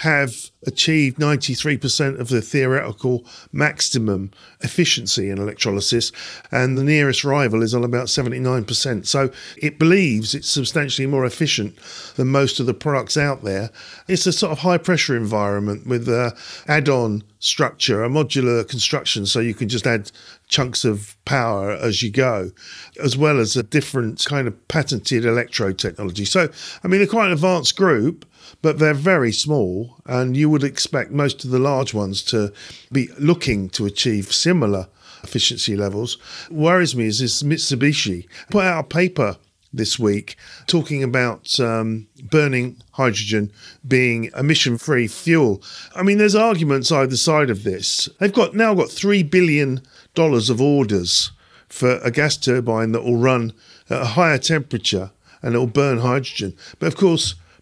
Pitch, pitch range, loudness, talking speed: 130 Hz, 115-150 Hz, -19 LUFS, 160 wpm